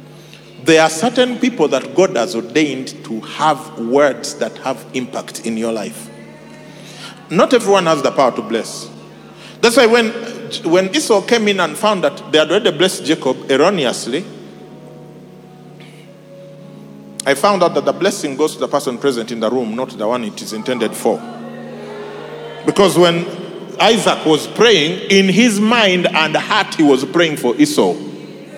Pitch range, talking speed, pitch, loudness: 140-200 Hz, 160 wpm, 170 Hz, -15 LUFS